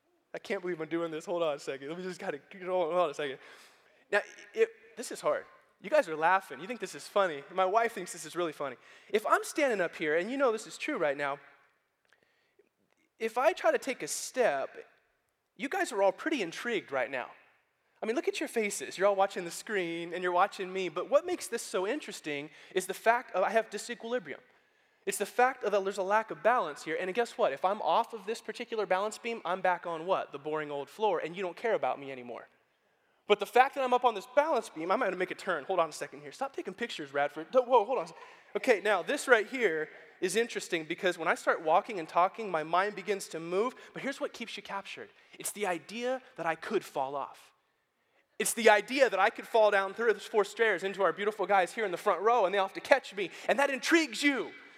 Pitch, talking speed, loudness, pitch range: 205 Hz, 250 wpm, -31 LUFS, 180-250 Hz